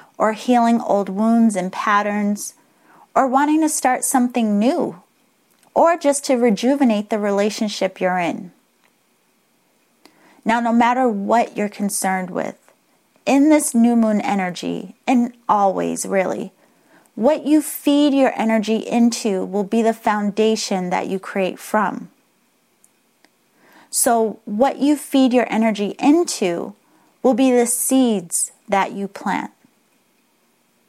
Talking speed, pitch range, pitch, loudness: 120 wpm, 205-260 Hz, 225 Hz, -18 LUFS